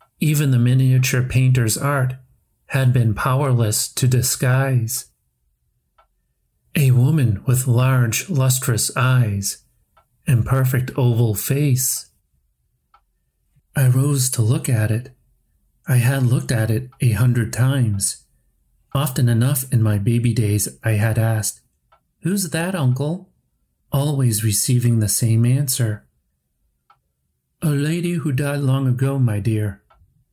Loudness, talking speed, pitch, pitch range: -19 LUFS, 115 wpm, 125 Hz, 110-135 Hz